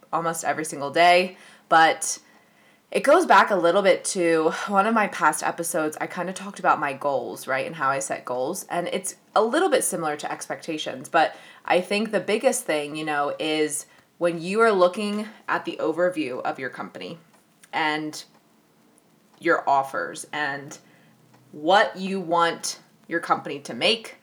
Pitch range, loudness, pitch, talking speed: 150-190 Hz, -23 LUFS, 170 Hz, 170 wpm